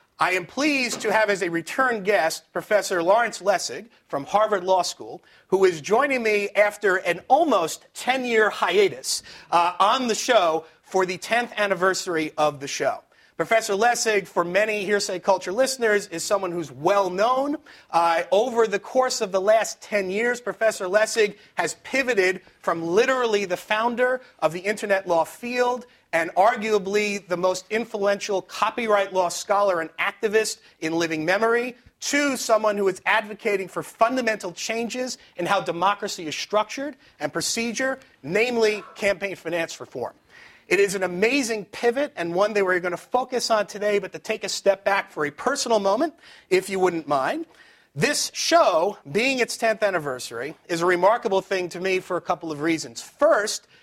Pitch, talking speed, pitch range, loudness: 205 Hz, 165 wpm, 180-230 Hz, -23 LUFS